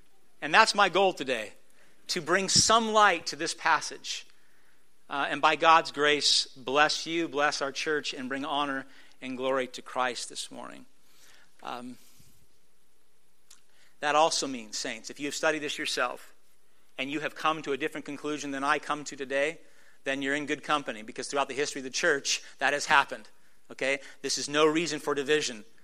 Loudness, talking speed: -27 LUFS, 180 wpm